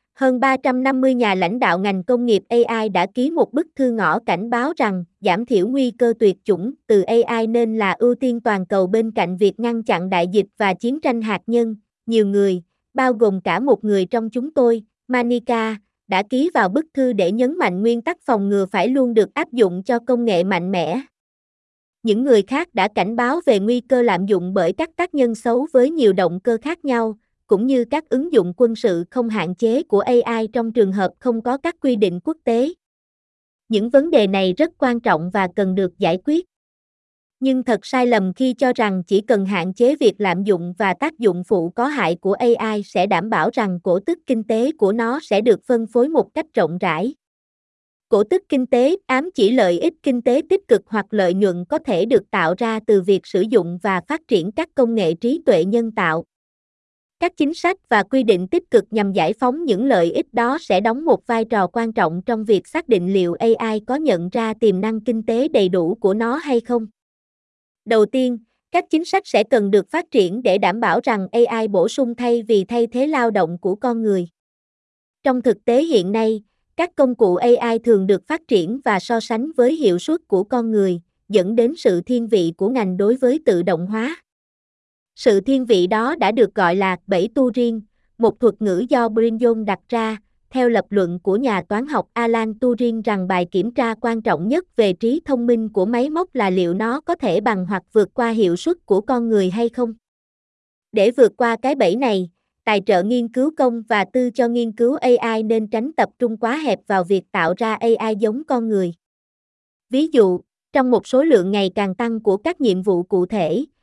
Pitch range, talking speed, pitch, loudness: 200-255 Hz, 215 wpm, 230 Hz, -18 LUFS